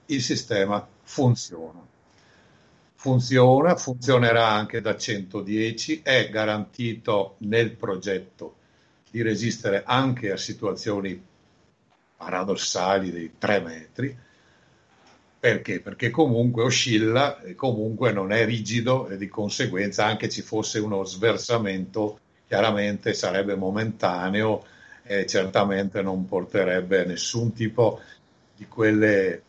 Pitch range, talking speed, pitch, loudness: 100-120 Hz, 100 wpm, 110 Hz, -24 LUFS